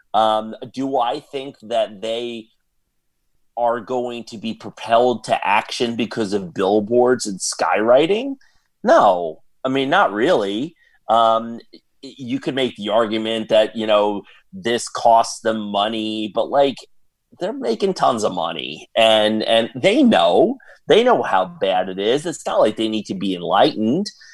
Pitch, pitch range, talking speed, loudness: 115 Hz, 110-125 Hz, 150 wpm, -18 LUFS